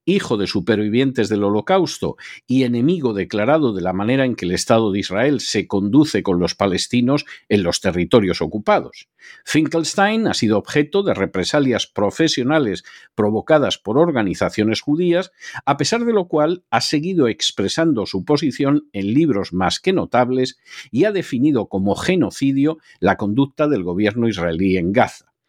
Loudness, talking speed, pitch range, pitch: -18 LUFS, 150 wpm, 100-150 Hz, 120 Hz